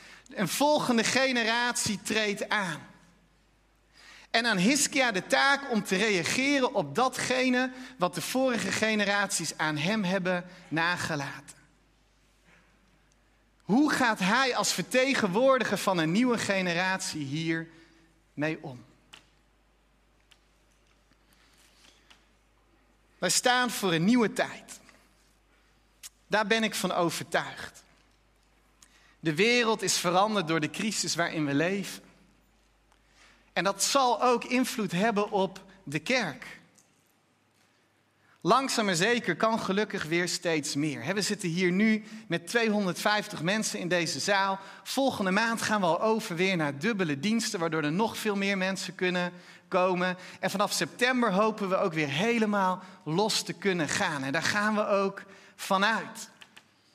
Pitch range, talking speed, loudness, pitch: 170-220 Hz, 125 wpm, -27 LUFS, 195 Hz